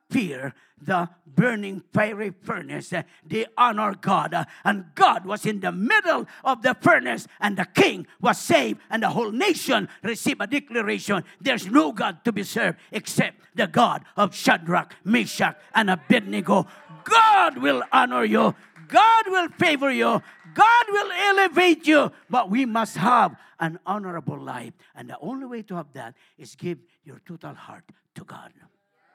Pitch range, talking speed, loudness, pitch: 185-270 Hz, 155 wpm, -22 LUFS, 215 Hz